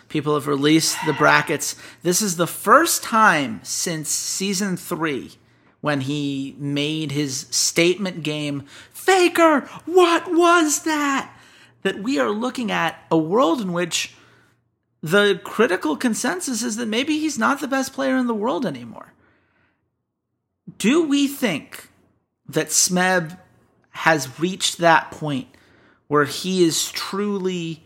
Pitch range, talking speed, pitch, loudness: 155-255 Hz, 130 wpm, 185 Hz, -20 LUFS